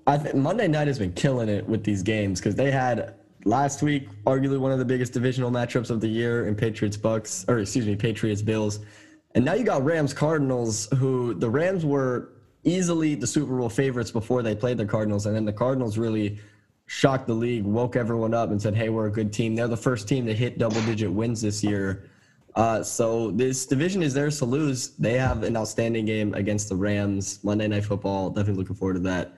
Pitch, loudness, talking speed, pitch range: 115 Hz, -25 LUFS, 220 wpm, 105-130 Hz